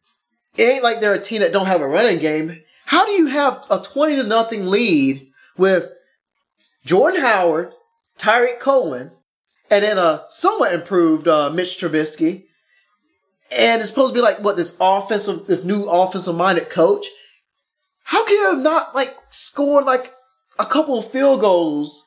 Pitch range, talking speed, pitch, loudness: 180-285 Hz, 165 wpm, 225 Hz, -17 LUFS